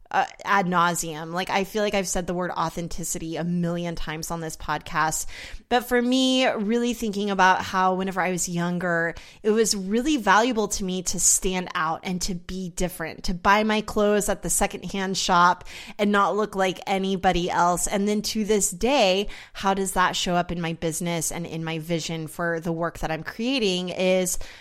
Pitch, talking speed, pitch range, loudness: 185 Hz, 195 wpm, 170-205 Hz, -24 LUFS